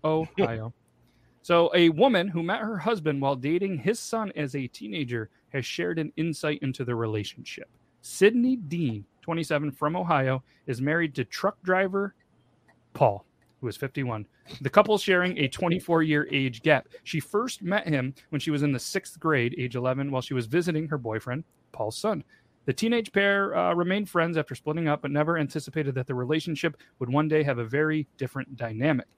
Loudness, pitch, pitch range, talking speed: -27 LUFS, 150 Hz, 130-175 Hz, 180 wpm